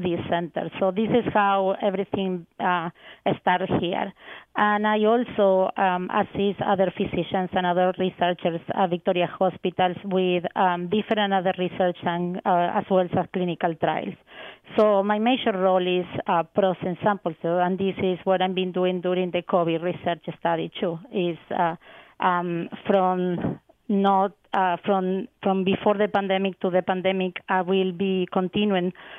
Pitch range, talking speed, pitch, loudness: 180-195 Hz, 150 wpm, 185 Hz, -24 LUFS